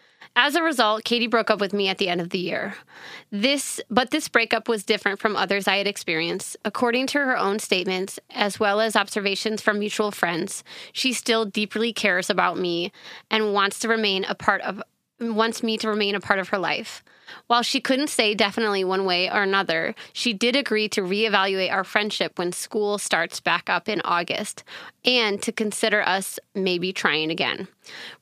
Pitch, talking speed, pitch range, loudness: 210 Hz, 190 wpm, 195-230 Hz, -23 LUFS